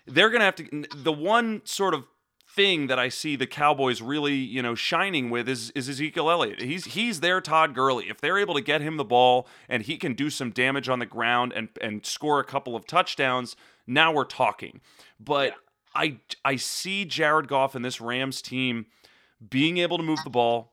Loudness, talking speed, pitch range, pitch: -25 LUFS, 210 wpm, 125-155 Hz, 135 Hz